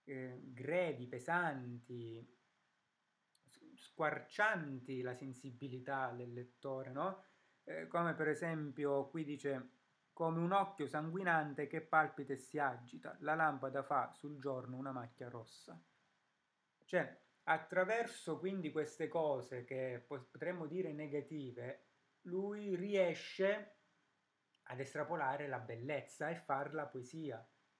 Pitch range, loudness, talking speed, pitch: 130-165 Hz, -41 LUFS, 110 wpm, 145 Hz